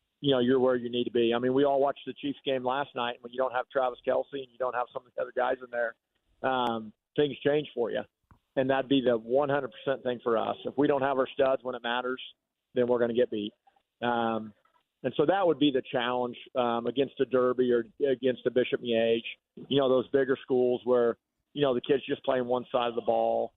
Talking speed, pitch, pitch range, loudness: 250 wpm, 125 Hz, 120-135 Hz, -29 LUFS